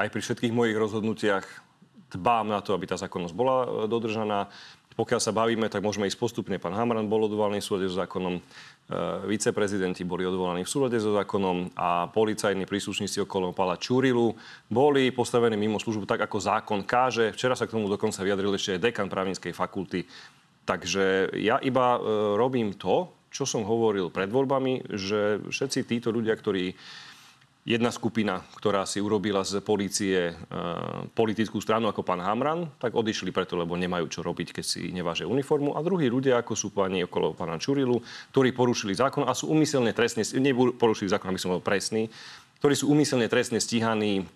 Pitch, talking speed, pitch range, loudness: 110 Hz, 170 wpm, 95-120 Hz, -27 LUFS